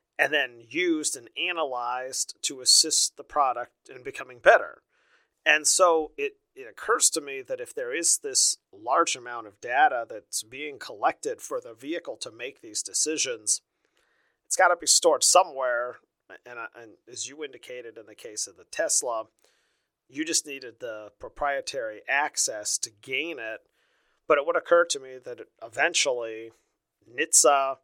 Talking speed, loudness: 155 wpm, -24 LUFS